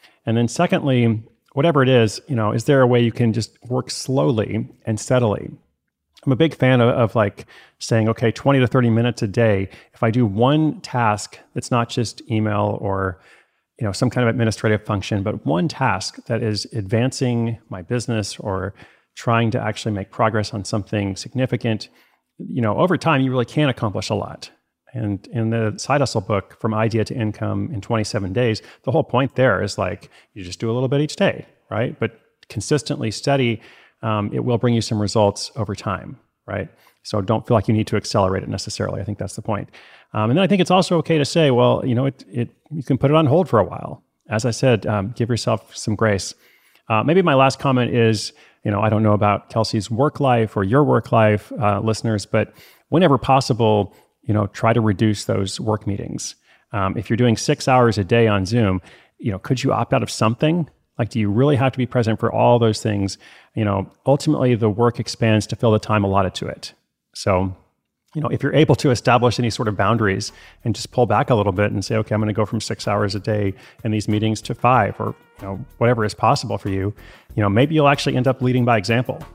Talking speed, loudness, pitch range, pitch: 225 wpm, -20 LUFS, 105-130 Hz, 115 Hz